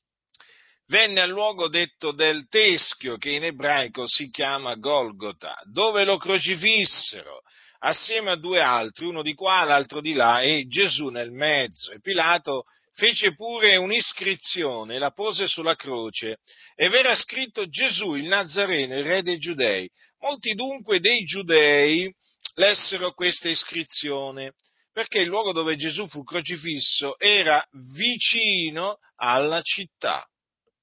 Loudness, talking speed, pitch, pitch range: -21 LUFS, 130 wpm, 175 Hz, 145-205 Hz